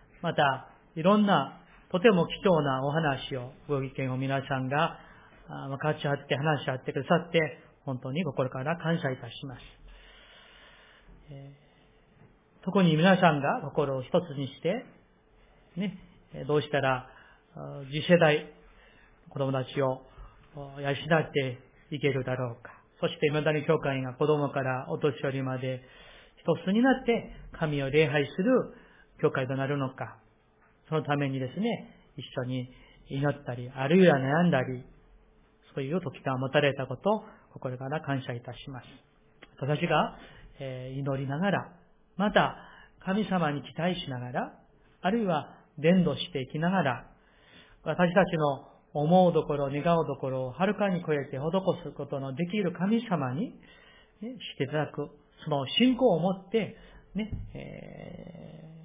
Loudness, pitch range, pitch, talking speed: -29 LUFS, 135-170 Hz, 150 Hz, 260 characters per minute